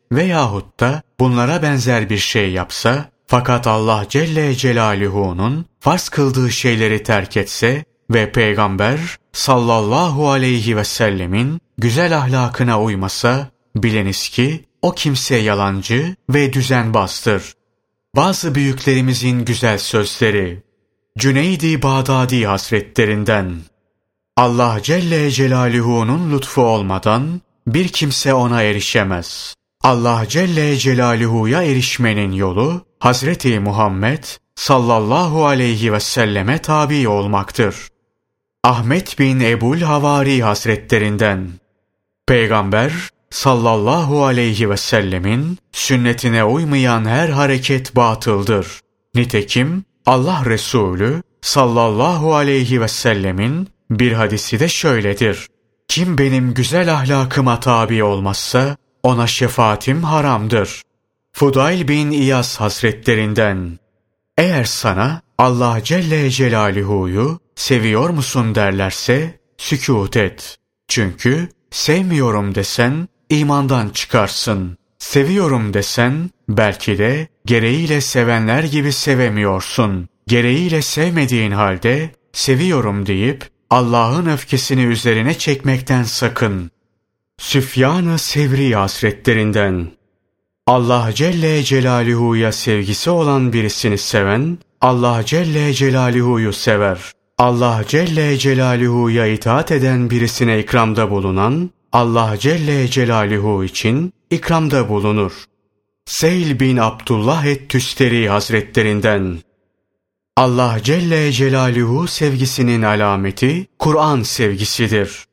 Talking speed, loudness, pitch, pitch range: 90 wpm, -15 LUFS, 120 Hz, 110-140 Hz